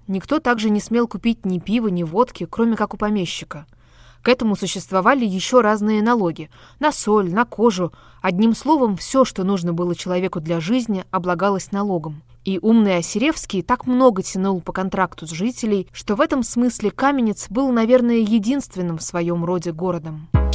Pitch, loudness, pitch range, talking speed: 200 Hz, -20 LUFS, 180-235 Hz, 165 wpm